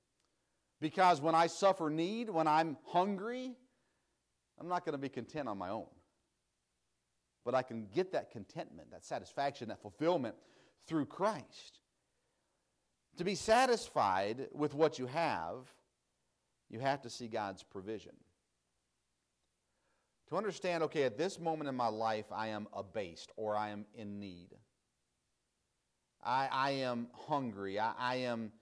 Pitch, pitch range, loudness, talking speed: 125 Hz, 100-165 Hz, -37 LUFS, 140 wpm